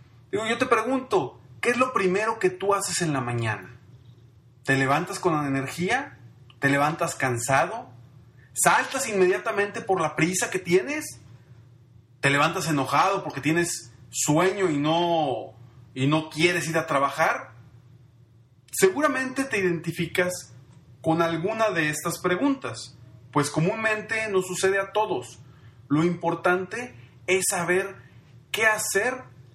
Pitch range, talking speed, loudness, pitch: 125-185 Hz, 125 wpm, -24 LUFS, 155 Hz